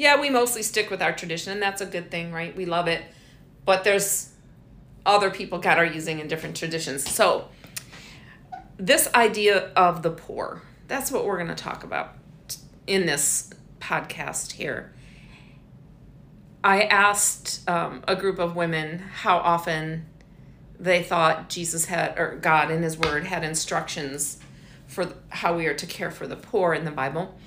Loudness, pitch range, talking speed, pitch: -24 LUFS, 160-195 Hz, 165 wpm, 175 Hz